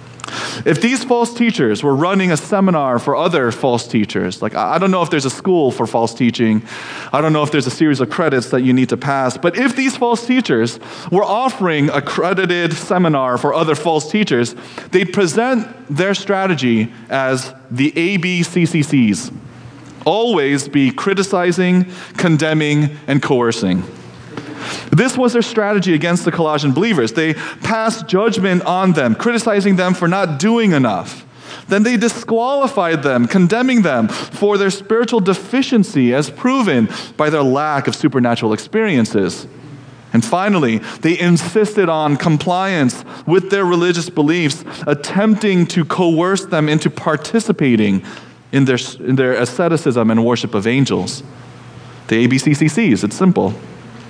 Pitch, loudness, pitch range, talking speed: 165 Hz, -15 LUFS, 135-200 Hz, 145 wpm